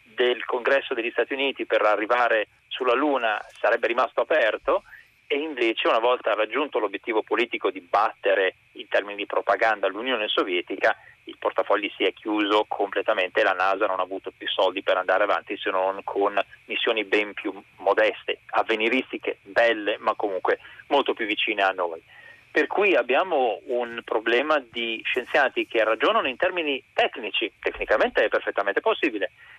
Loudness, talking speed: -24 LUFS, 150 wpm